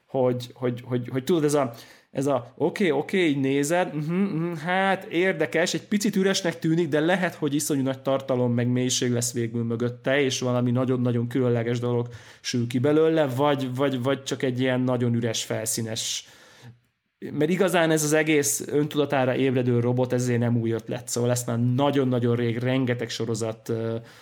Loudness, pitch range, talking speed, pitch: -24 LUFS, 120-150 Hz, 175 wpm, 130 Hz